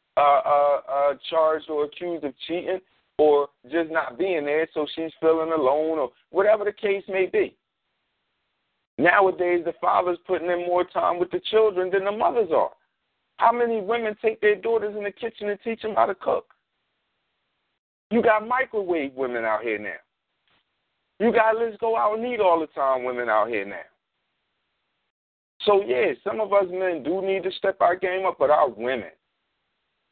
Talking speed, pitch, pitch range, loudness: 175 wpm, 185 Hz, 160-215 Hz, -23 LUFS